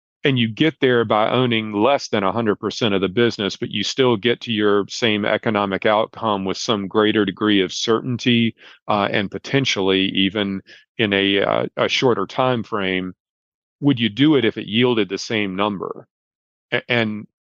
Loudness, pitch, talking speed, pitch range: -19 LUFS, 105 Hz, 170 wpm, 100-120 Hz